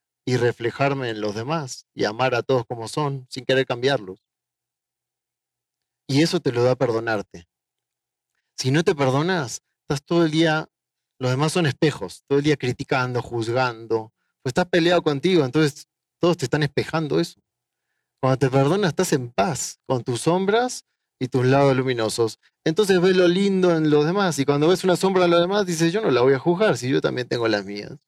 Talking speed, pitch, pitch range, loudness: 190 wpm, 140 Hz, 125-170 Hz, -21 LUFS